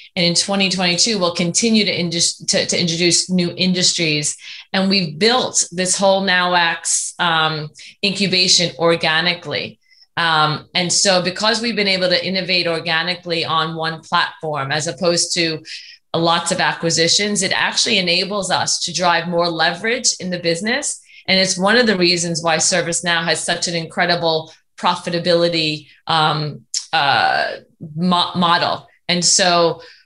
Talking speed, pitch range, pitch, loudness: 140 wpm, 165-185 Hz, 175 Hz, -16 LUFS